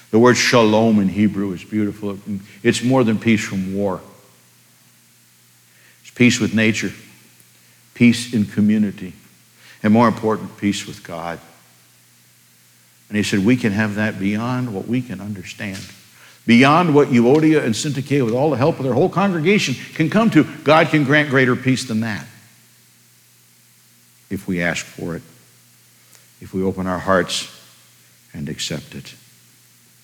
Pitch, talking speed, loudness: 105 Hz, 150 wpm, -18 LUFS